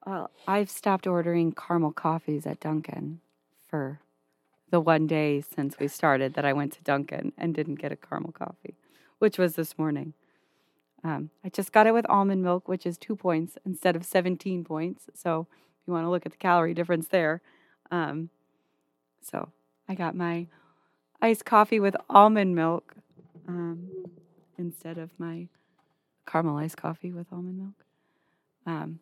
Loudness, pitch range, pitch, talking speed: -27 LUFS, 155-180 Hz, 170 Hz, 160 wpm